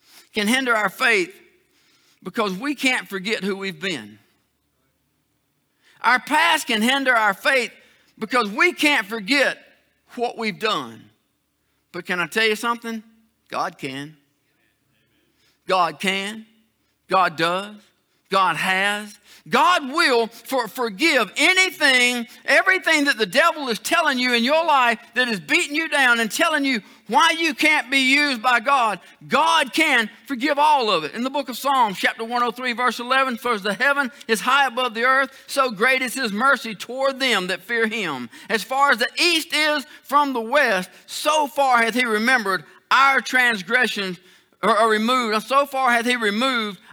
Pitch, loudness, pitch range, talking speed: 250 Hz, -19 LUFS, 220-285 Hz, 160 wpm